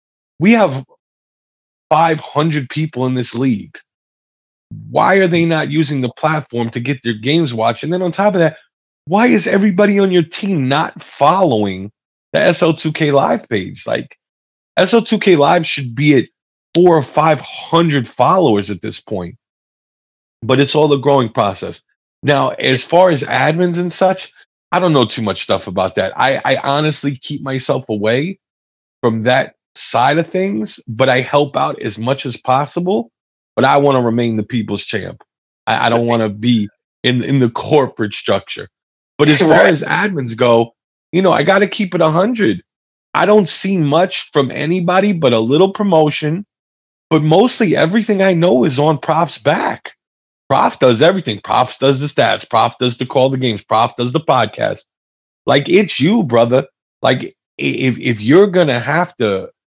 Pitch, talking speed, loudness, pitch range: 140 Hz, 170 wpm, -14 LUFS, 120-170 Hz